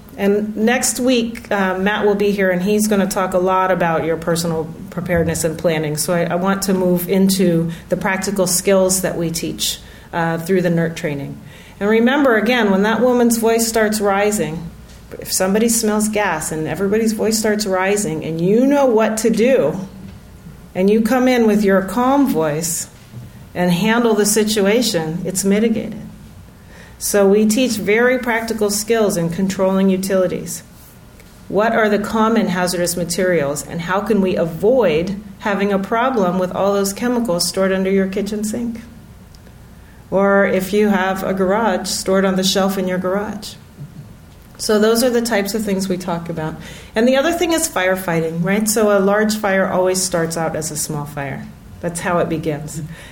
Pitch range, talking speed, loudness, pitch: 175-215 Hz, 175 wpm, -17 LUFS, 195 Hz